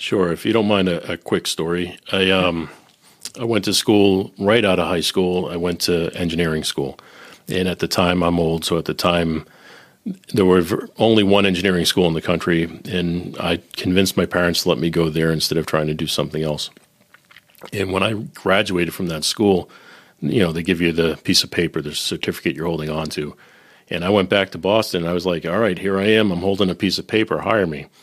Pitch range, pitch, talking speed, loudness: 80-95 Hz, 90 Hz, 225 wpm, -19 LUFS